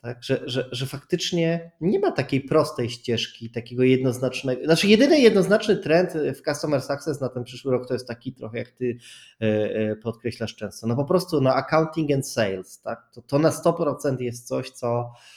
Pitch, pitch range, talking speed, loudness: 130 Hz, 120-155 Hz, 190 wpm, -23 LUFS